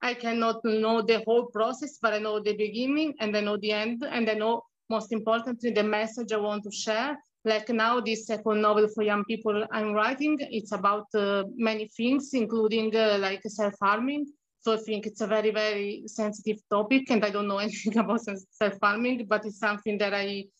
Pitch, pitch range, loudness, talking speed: 220 Hz, 210-230 Hz, -28 LUFS, 190 wpm